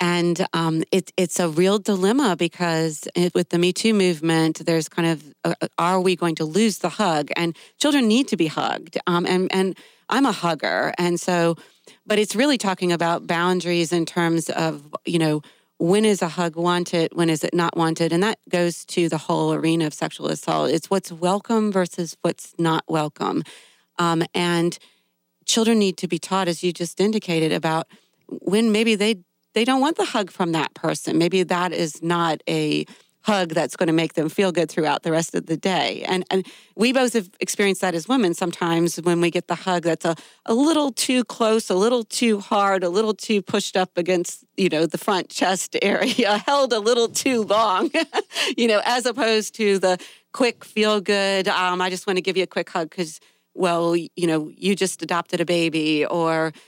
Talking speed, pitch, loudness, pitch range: 200 wpm, 180 Hz, -21 LUFS, 170-210 Hz